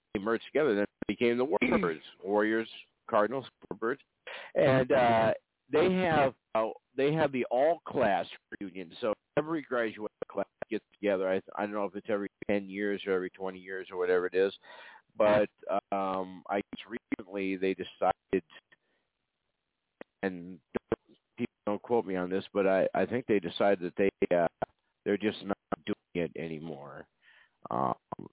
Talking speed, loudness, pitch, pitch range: 155 wpm, -31 LUFS, 100 Hz, 95-110 Hz